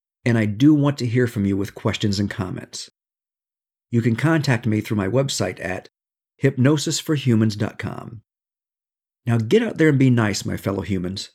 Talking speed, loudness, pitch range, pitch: 165 wpm, -20 LUFS, 100-135 Hz, 115 Hz